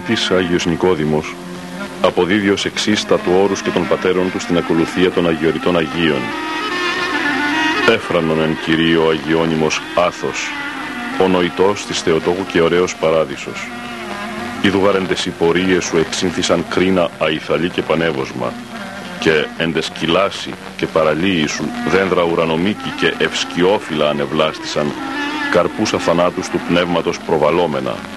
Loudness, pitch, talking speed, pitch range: -16 LUFS, 90 Hz, 110 wpm, 80-95 Hz